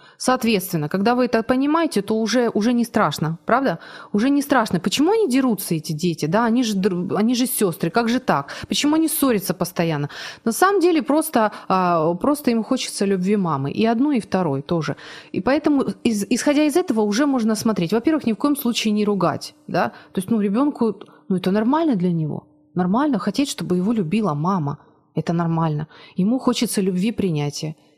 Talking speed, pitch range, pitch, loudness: 180 wpm, 180-255 Hz, 215 Hz, -20 LUFS